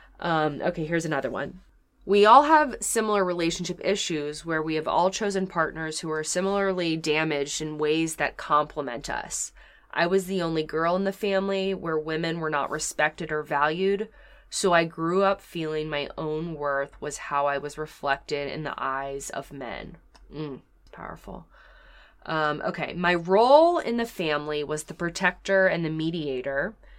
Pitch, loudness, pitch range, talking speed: 160 Hz, -25 LUFS, 150-190 Hz, 165 wpm